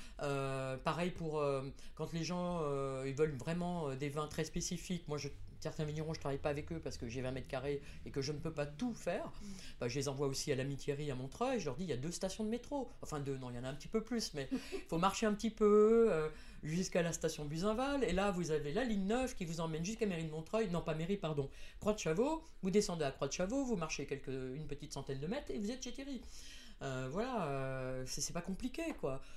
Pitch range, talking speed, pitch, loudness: 140-210 Hz, 265 wpm, 160 Hz, -39 LUFS